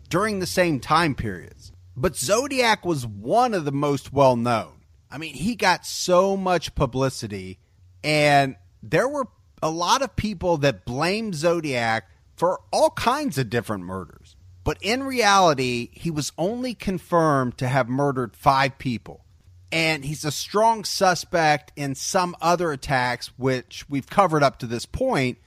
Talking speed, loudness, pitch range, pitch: 155 wpm, -22 LUFS, 120-175 Hz, 140 Hz